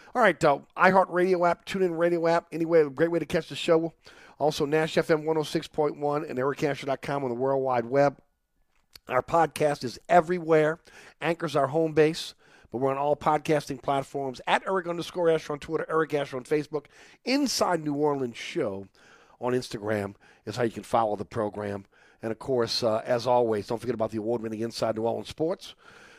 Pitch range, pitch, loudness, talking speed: 125-165 Hz, 145 Hz, -27 LUFS, 185 wpm